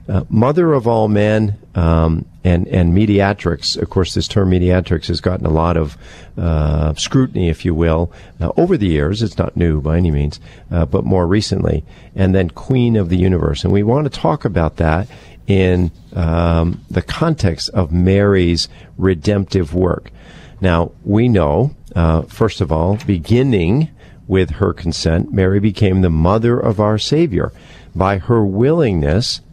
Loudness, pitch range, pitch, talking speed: -16 LUFS, 85-110 Hz, 95 Hz, 165 wpm